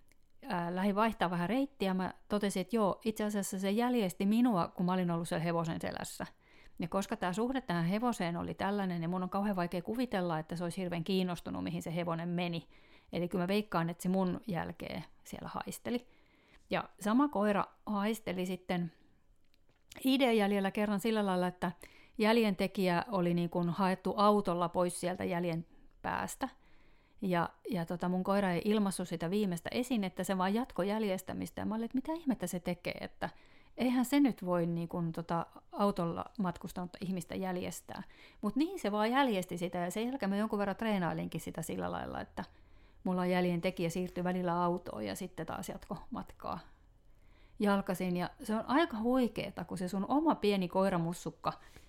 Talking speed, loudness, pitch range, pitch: 175 wpm, -35 LUFS, 175-210 Hz, 185 Hz